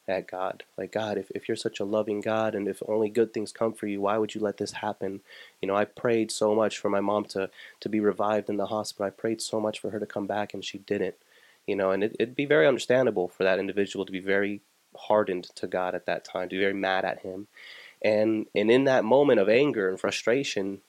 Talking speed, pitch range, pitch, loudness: 255 wpm, 100-110 Hz, 105 Hz, -27 LUFS